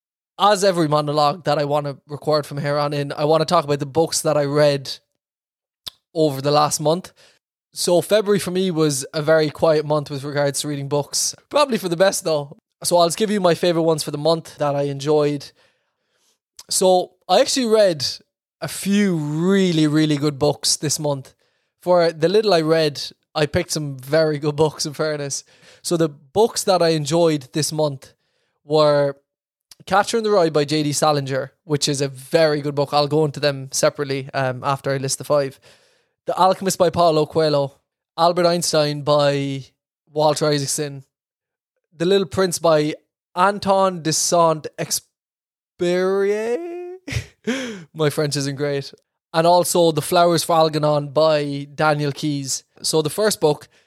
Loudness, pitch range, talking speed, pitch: -19 LUFS, 145-175 Hz, 170 wpm, 155 Hz